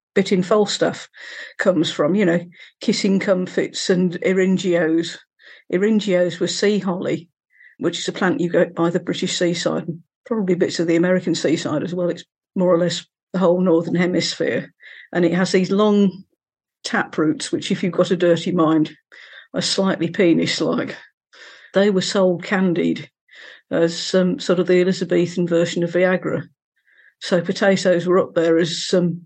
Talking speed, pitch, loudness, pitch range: 170 wpm, 180 Hz, -19 LUFS, 170-190 Hz